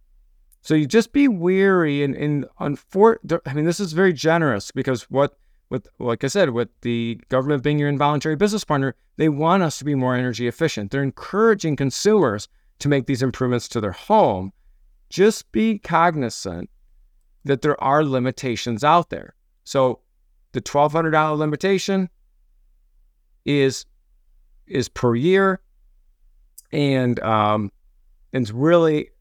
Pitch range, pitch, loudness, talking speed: 115-165 Hz, 140 Hz, -20 LUFS, 140 wpm